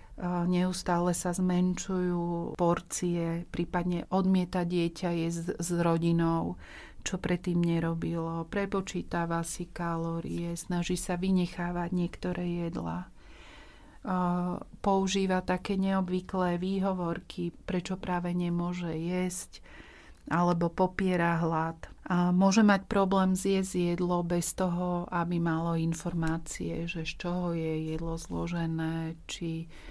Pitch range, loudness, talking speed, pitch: 170-180 Hz, -31 LUFS, 100 wpm, 175 Hz